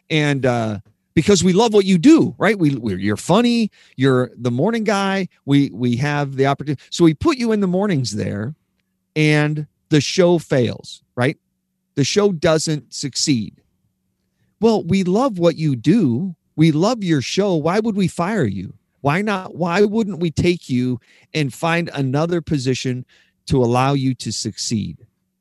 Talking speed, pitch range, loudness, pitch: 165 wpm, 125-185 Hz, -18 LUFS, 150 Hz